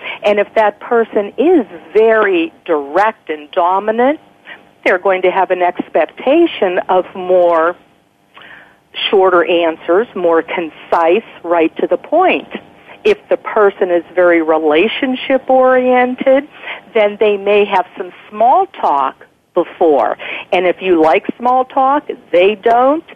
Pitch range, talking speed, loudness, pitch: 175-260 Hz, 125 wpm, -13 LUFS, 205 Hz